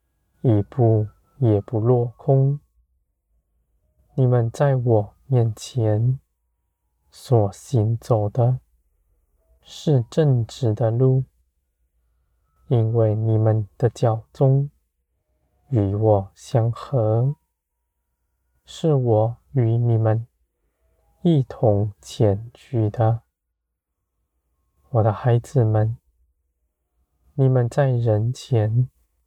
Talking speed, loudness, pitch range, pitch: 105 characters per minute, -21 LUFS, 70-120 Hz, 105 Hz